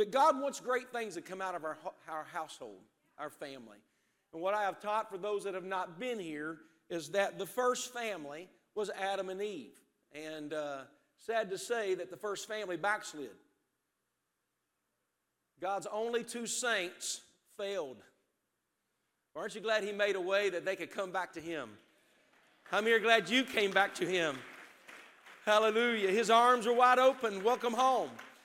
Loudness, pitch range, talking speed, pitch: -33 LUFS, 180-230 Hz, 170 wpm, 200 Hz